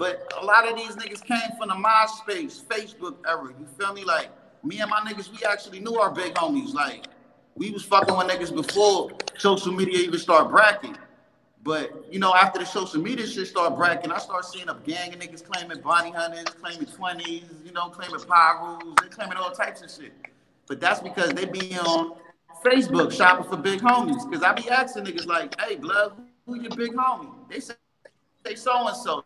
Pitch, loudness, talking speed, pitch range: 195 Hz, -23 LUFS, 200 wpm, 175-240 Hz